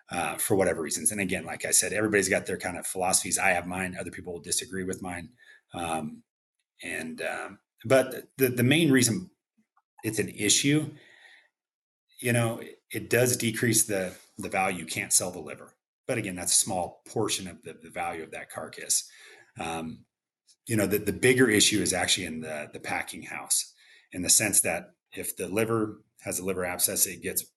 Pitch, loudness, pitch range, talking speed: 110 Hz, -26 LUFS, 90-125 Hz, 195 wpm